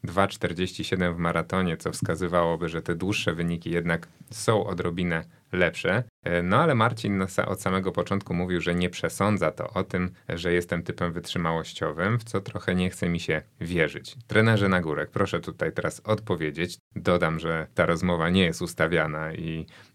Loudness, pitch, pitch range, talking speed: -26 LUFS, 90 Hz, 85-100 Hz, 160 wpm